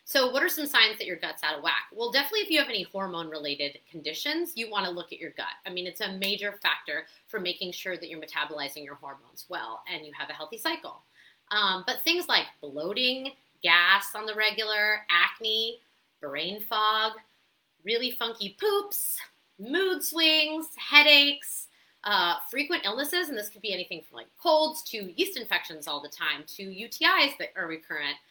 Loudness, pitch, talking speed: -26 LUFS, 215 Hz, 185 wpm